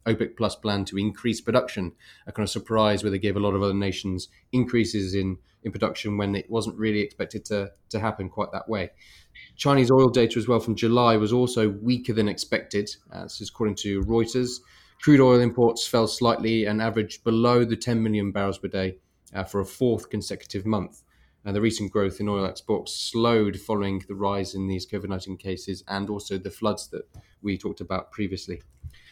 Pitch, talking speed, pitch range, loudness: 105 Hz, 200 wpm, 95-115 Hz, -25 LUFS